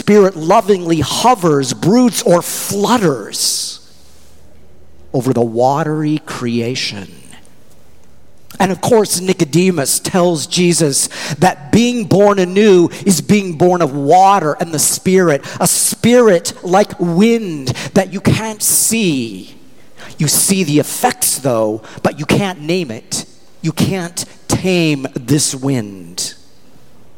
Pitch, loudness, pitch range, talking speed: 170 Hz, -13 LUFS, 135-195 Hz, 115 wpm